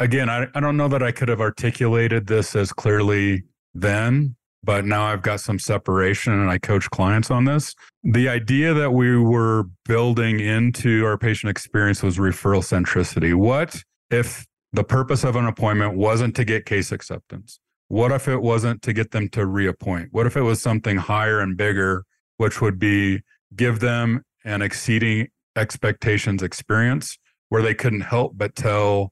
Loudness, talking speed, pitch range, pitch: -21 LUFS, 170 wpm, 100-120 Hz, 110 Hz